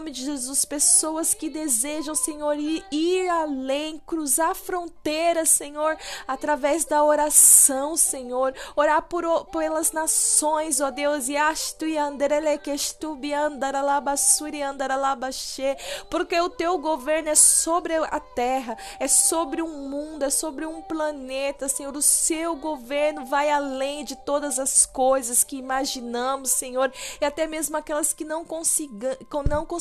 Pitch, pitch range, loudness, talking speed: 300 Hz, 275-315 Hz, -22 LUFS, 135 wpm